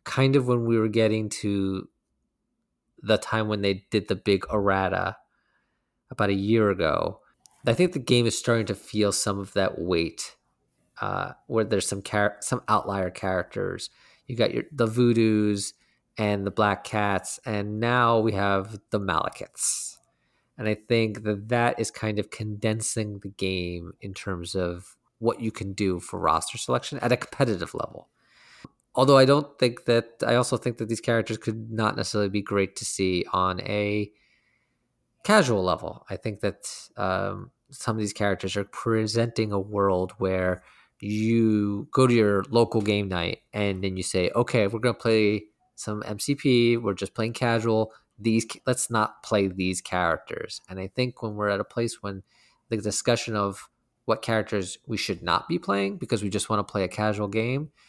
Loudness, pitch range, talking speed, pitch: -26 LUFS, 100-115 Hz, 175 wpm, 105 Hz